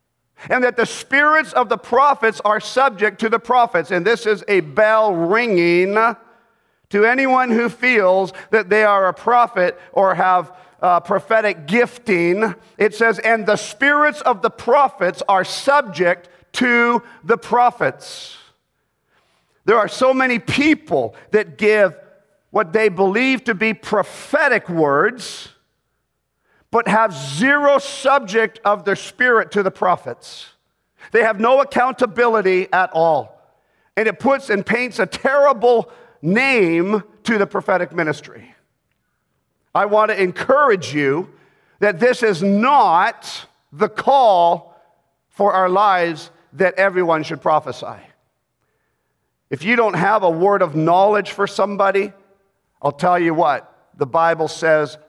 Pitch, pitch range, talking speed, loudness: 210 Hz, 180-235 Hz, 135 wpm, -16 LUFS